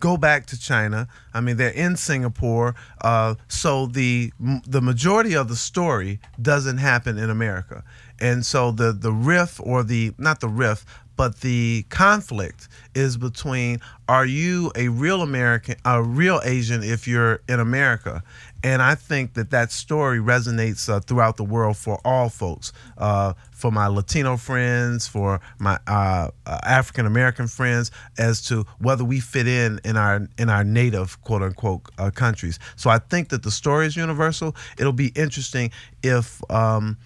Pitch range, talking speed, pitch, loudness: 110-130 Hz, 165 wpm, 120 Hz, -21 LUFS